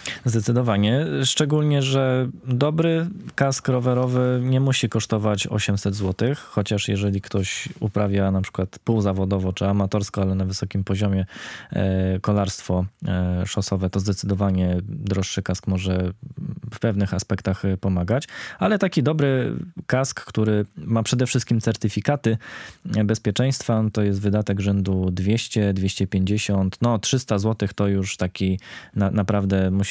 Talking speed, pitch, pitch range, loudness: 120 wpm, 105 Hz, 95-125 Hz, -23 LUFS